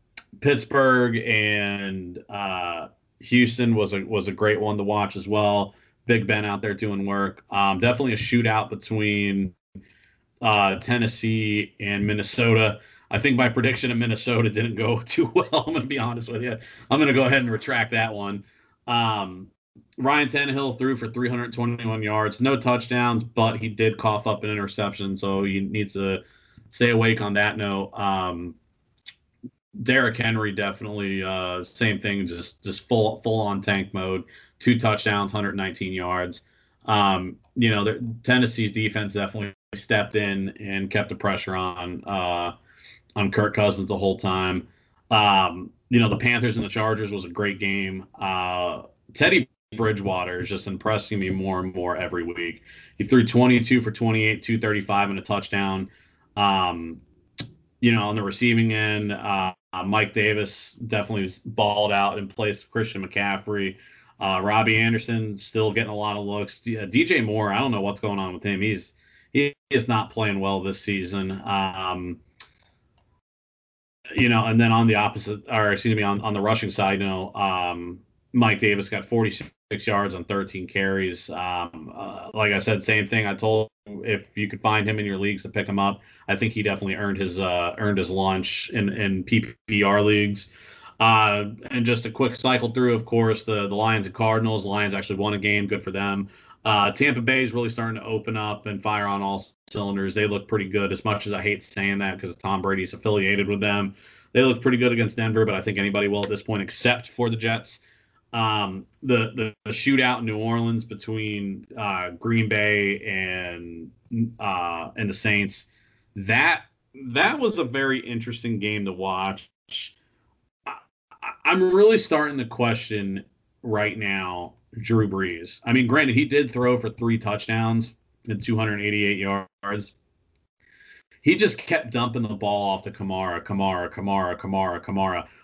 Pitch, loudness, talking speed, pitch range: 105 Hz, -23 LUFS, 175 wpm, 100-115 Hz